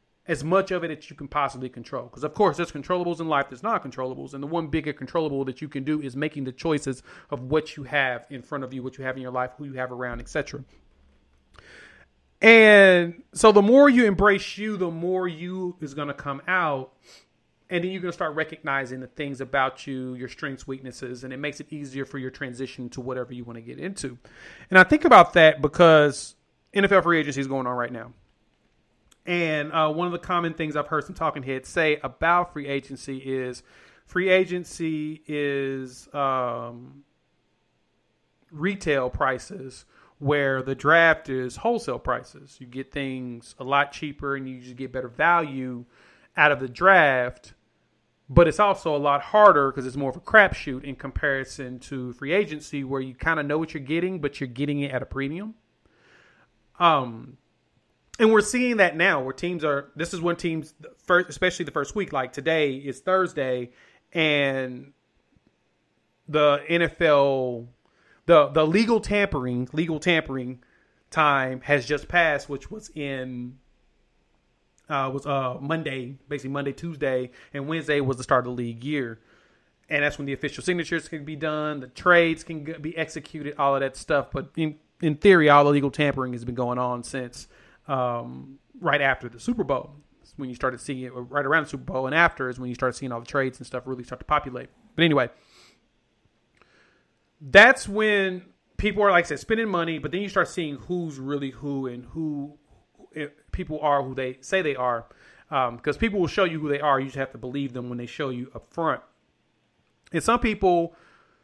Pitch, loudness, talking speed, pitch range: 145 Hz, -23 LUFS, 190 wpm, 130-165 Hz